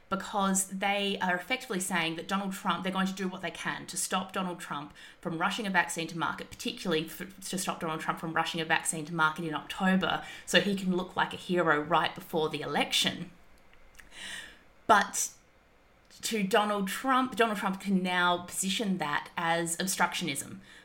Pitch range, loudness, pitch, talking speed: 165-195 Hz, -30 LUFS, 180 Hz, 180 wpm